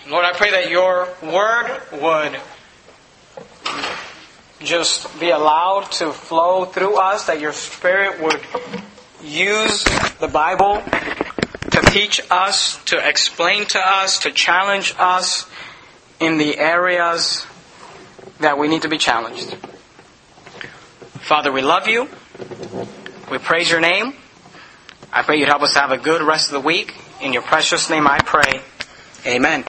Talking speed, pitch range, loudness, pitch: 135 wpm, 155-190 Hz, -16 LUFS, 170 Hz